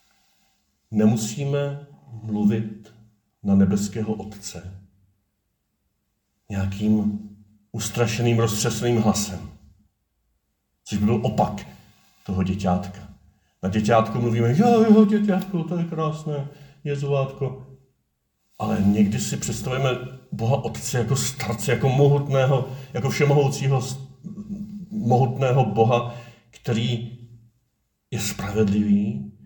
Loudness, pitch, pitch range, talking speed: -22 LUFS, 115 Hz, 105-135 Hz, 90 wpm